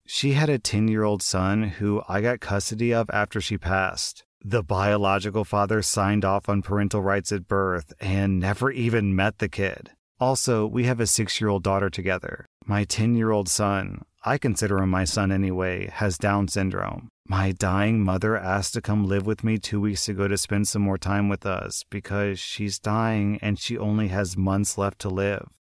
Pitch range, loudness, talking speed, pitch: 95-110 Hz, -24 LUFS, 195 wpm, 100 Hz